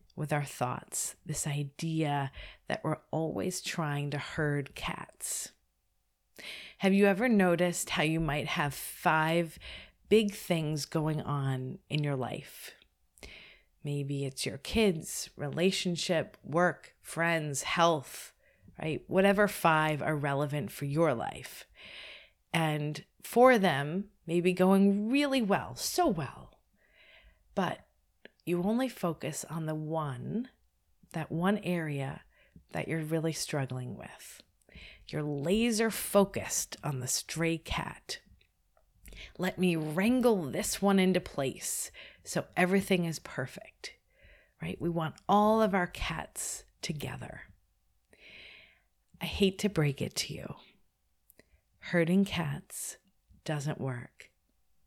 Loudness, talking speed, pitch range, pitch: -31 LUFS, 115 wpm, 150-190 Hz, 165 Hz